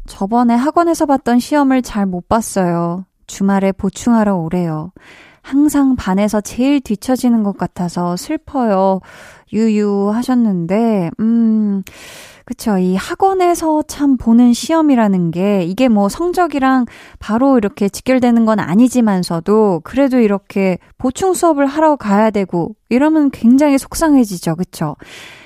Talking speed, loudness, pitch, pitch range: 285 characters per minute, -14 LUFS, 225 Hz, 195-265 Hz